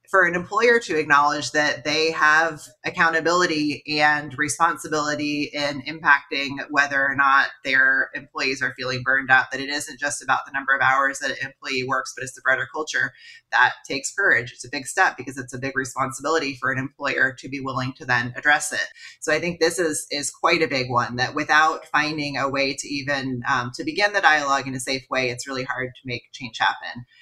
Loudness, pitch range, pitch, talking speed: -21 LUFS, 130-155 Hz, 140 Hz, 210 wpm